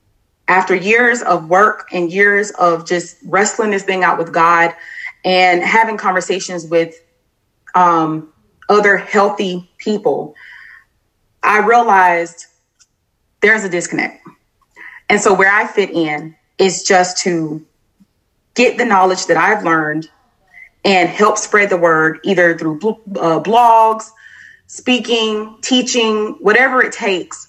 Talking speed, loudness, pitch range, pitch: 120 wpm, -13 LUFS, 170-215 Hz, 185 Hz